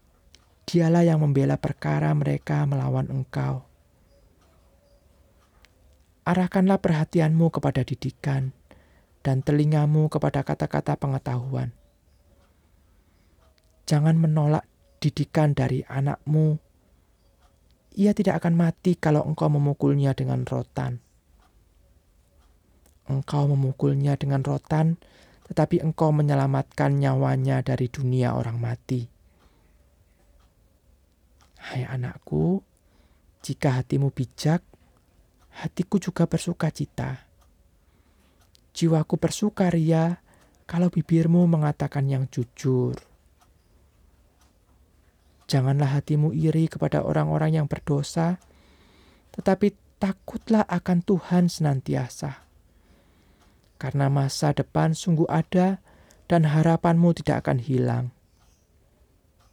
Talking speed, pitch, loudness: 80 wpm, 130 Hz, -24 LUFS